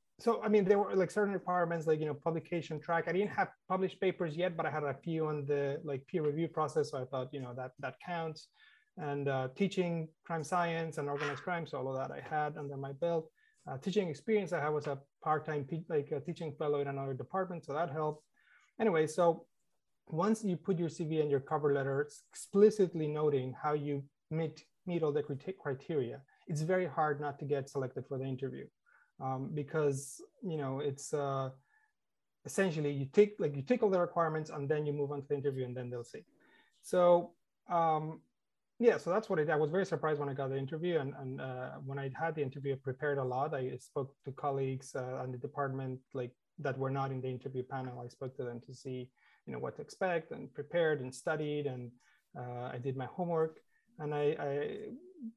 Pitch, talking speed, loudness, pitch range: 150 Hz, 215 wpm, -36 LUFS, 135-170 Hz